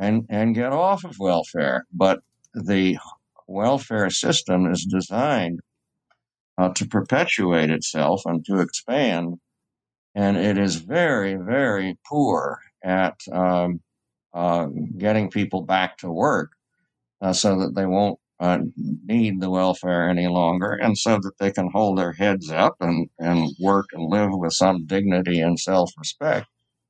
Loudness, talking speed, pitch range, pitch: -22 LUFS, 145 wpm, 90-105 Hz, 95 Hz